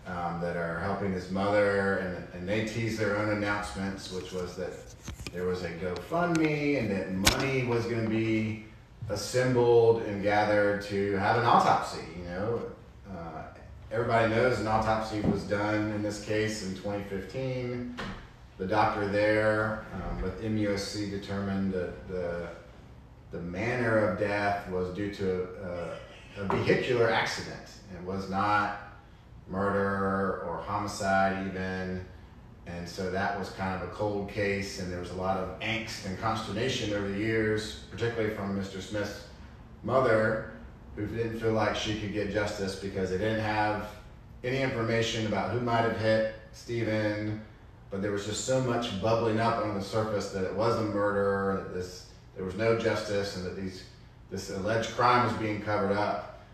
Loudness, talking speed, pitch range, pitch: -30 LUFS, 165 wpm, 95-110 Hz, 105 Hz